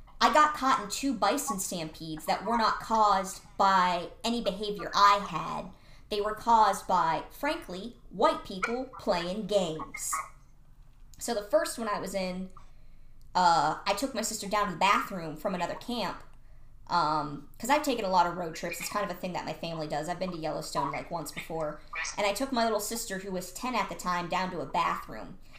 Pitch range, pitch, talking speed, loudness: 170-220 Hz, 195 Hz, 200 wpm, -29 LUFS